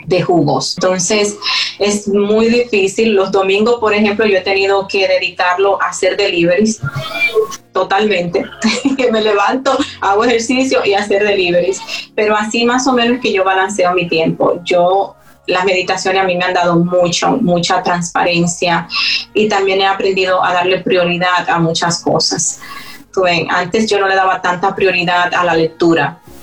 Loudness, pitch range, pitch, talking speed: -13 LUFS, 180-210 Hz, 195 Hz, 160 wpm